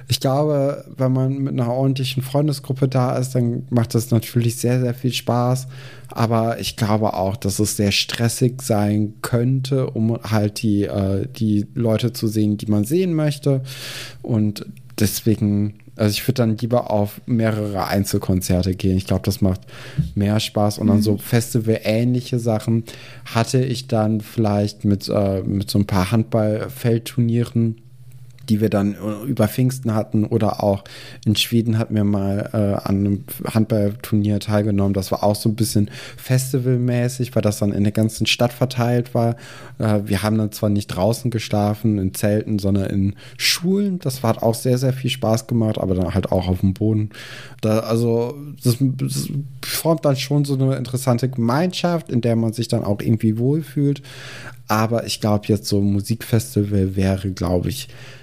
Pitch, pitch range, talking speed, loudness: 115 Hz, 105-130 Hz, 170 wpm, -20 LUFS